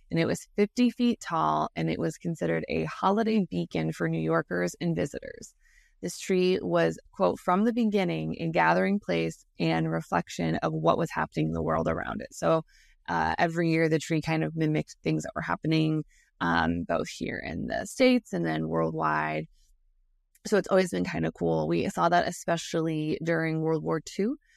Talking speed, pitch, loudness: 185 wpm, 150 Hz, -28 LUFS